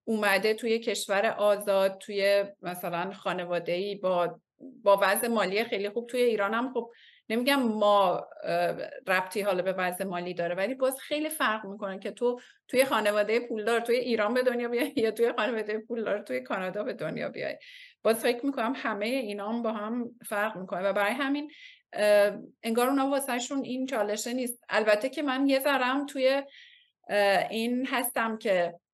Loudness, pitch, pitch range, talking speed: -28 LUFS, 225 Hz, 200-255 Hz, 160 wpm